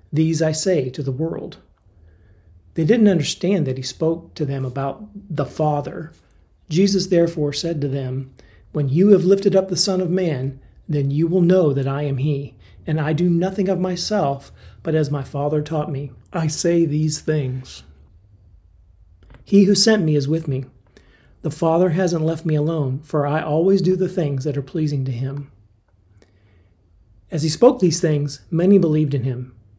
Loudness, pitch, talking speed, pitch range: -20 LUFS, 150 Hz, 175 wpm, 130-170 Hz